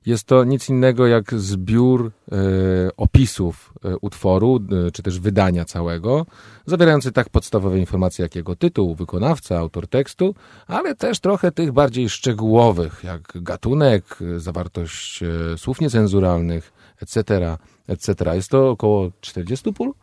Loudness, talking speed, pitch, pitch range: -19 LUFS, 130 wpm, 100 Hz, 90-130 Hz